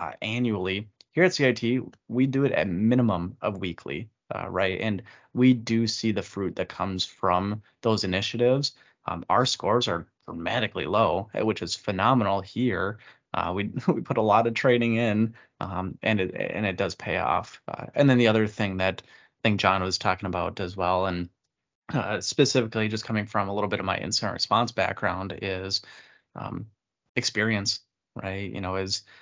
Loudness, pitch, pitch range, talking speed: -26 LUFS, 105 Hz, 95-115 Hz, 180 wpm